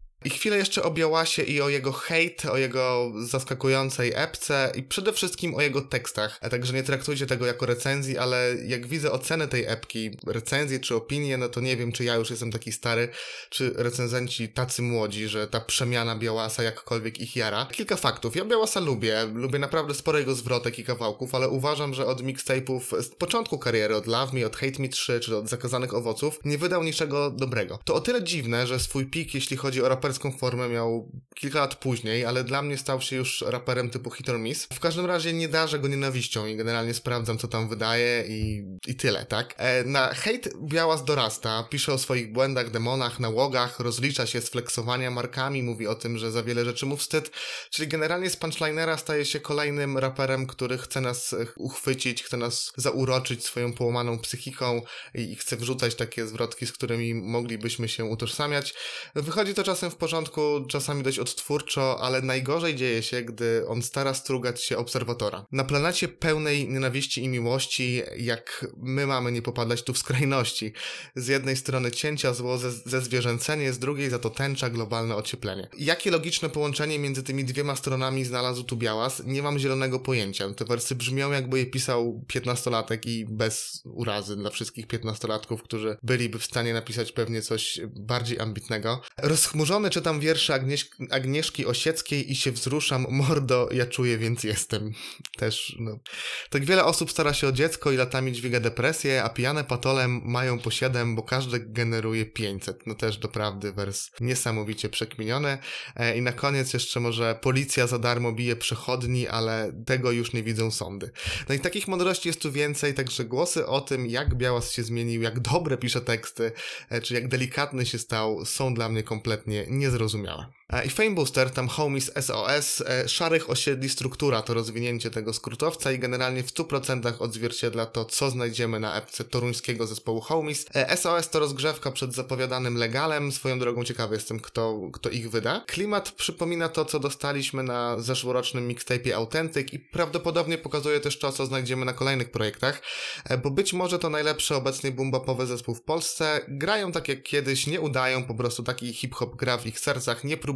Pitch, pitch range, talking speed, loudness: 130 Hz, 120-140 Hz, 175 wpm, -27 LUFS